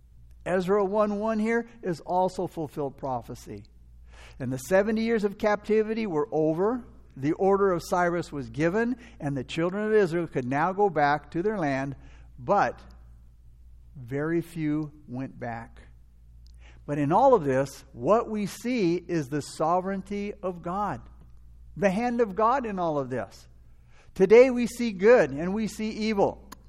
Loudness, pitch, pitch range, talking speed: -26 LUFS, 165 Hz, 125-205 Hz, 150 wpm